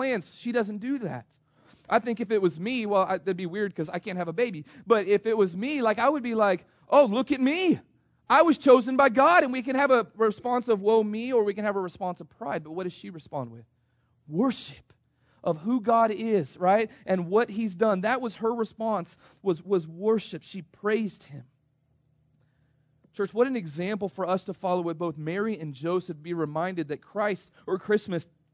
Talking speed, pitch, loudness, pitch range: 215 wpm, 200 Hz, -26 LUFS, 170-225 Hz